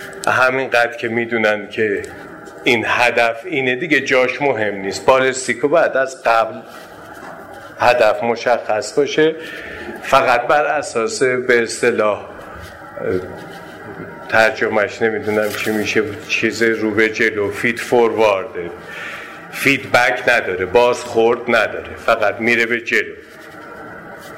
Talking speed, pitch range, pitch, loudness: 100 wpm, 110-130 Hz, 120 Hz, -16 LUFS